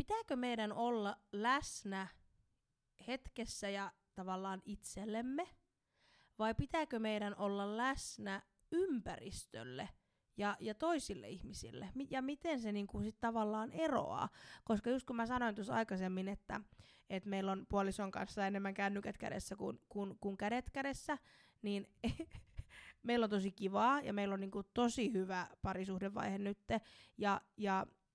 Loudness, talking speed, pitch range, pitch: -41 LUFS, 130 wpm, 195-240 Hz, 205 Hz